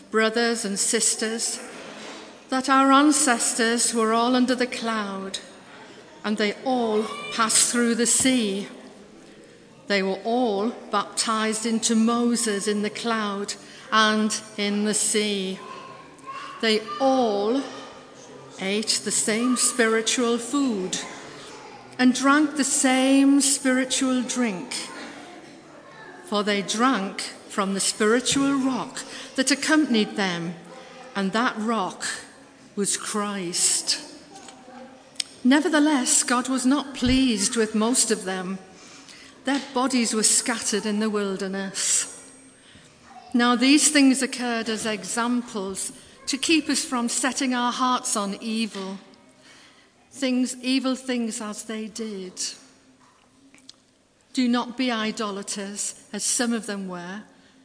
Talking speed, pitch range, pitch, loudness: 110 wpm, 210-260 Hz, 230 Hz, -23 LUFS